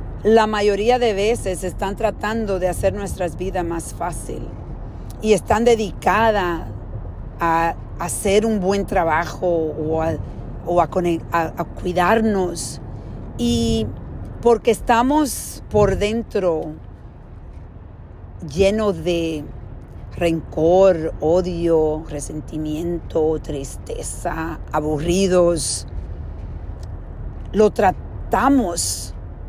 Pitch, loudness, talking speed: 165 Hz, -20 LUFS, 90 wpm